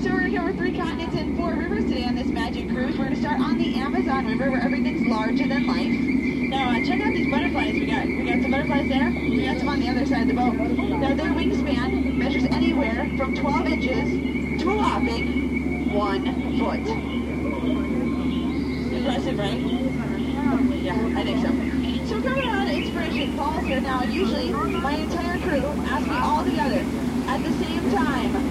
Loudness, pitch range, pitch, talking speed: -23 LUFS, 255-275 Hz, 265 Hz, 185 wpm